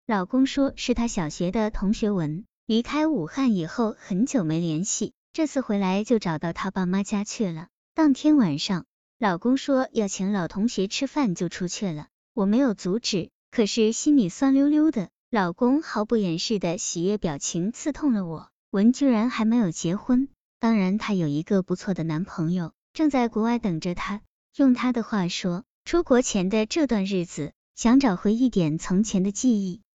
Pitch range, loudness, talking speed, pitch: 185-245 Hz, -24 LUFS, 260 characters per minute, 210 Hz